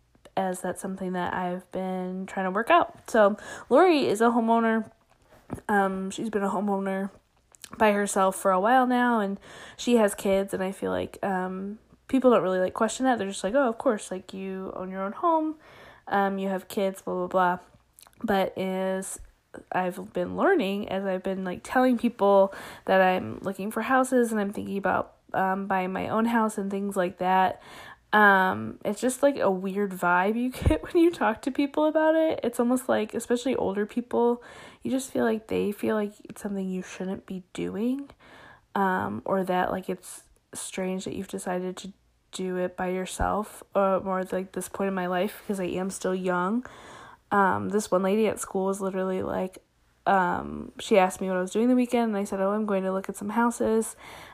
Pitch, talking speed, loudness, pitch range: 195 Hz, 200 wpm, -26 LUFS, 185-225 Hz